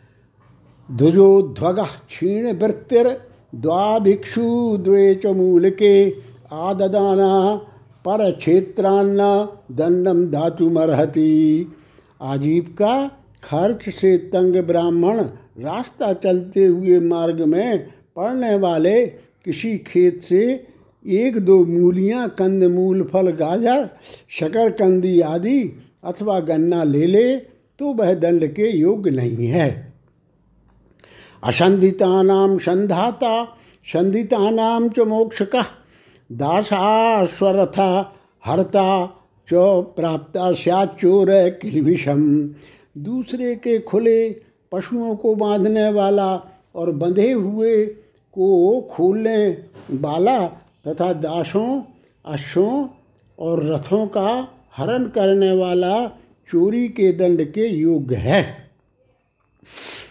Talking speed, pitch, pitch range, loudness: 85 wpm, 190 Hz, 170-215 Hz, -18 LUFS